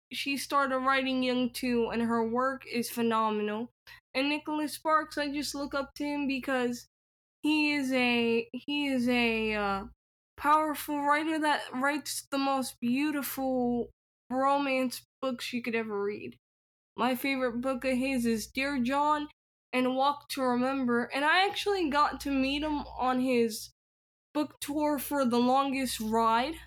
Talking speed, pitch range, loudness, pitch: 150 wpm, 240-285 Hz, -30 LUFS, 265 Hz